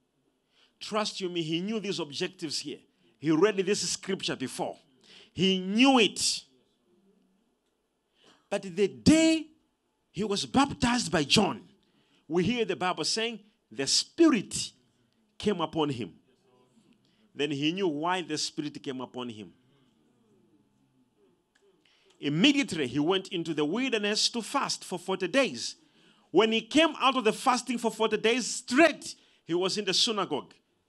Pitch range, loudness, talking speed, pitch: 160-230 Hz, -28 LUFS, 135 wpm, 195 Hz